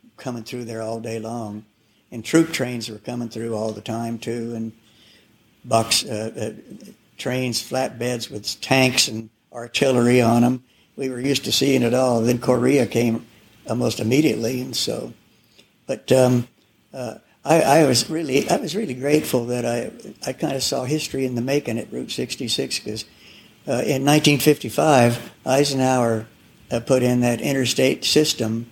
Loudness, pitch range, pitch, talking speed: -21 LUFS, 115-130 Hz, 120 Hz, 165 wpm